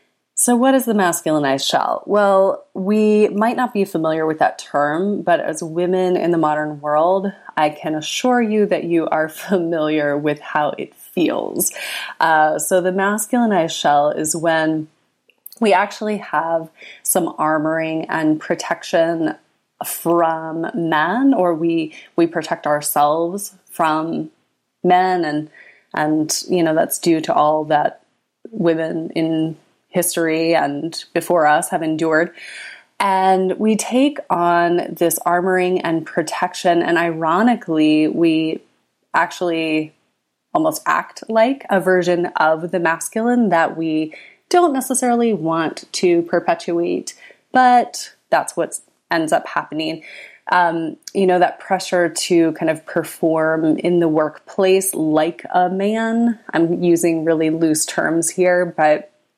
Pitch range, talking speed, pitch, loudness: 160-195 Hz, 130 wpm, 170 Hz, -18 LUFS